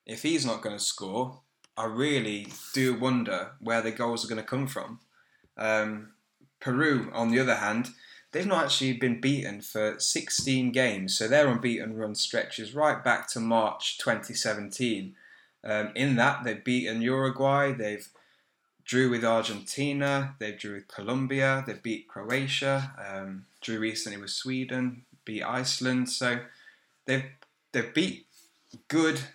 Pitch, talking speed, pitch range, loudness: 120 Hz, 145 wpm, 110-135 Hz, -28 LUFS